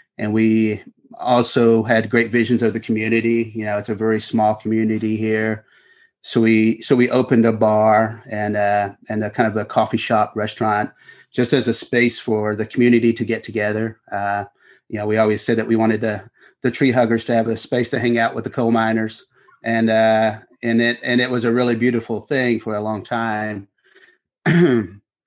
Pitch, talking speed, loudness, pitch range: 115 Hz, 195 wpm, -19 LUFS, 110-120 Hz